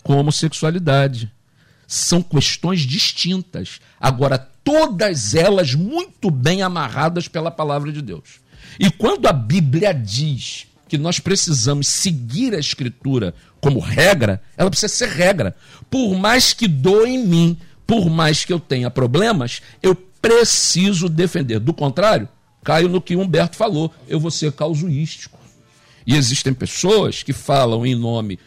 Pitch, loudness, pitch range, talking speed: 155 Hz, -17 LUFS, 135-185 Hz, 135 wpm